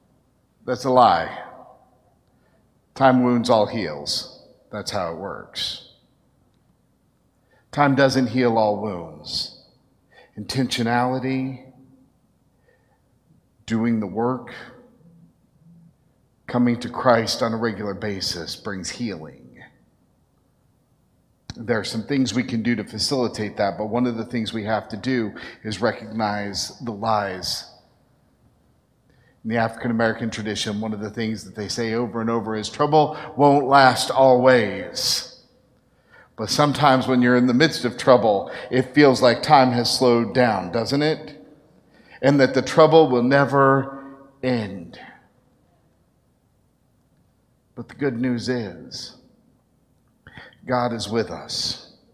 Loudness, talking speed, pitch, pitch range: -21 LUFS, 120 wpm, 125 Hz, 110-130 Hz